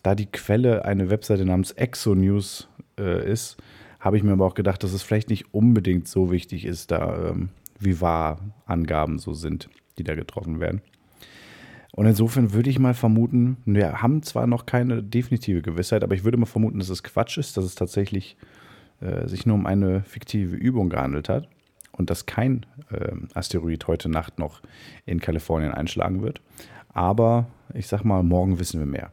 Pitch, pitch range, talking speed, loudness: 100 Hz, 90-115 Hz, 180 wpm, -24 LUFS